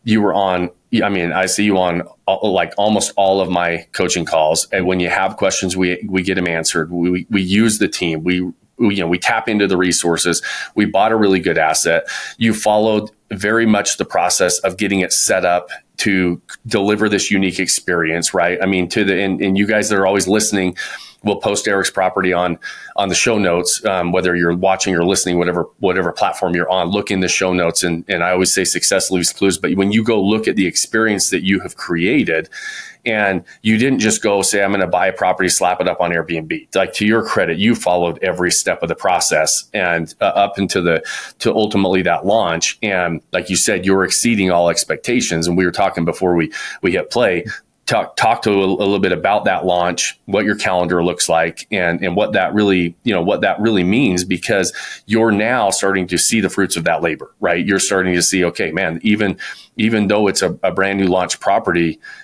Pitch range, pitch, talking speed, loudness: 90-100 Hz, 95 Hz, 225 wpm, -16 LUFS